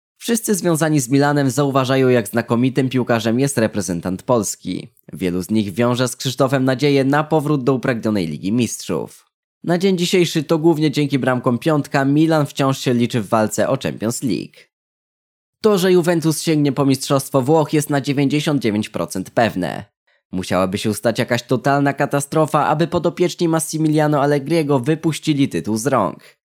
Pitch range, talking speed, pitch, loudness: 120-155 Hz, 150 wpm, 140 Hz, -18 LUFS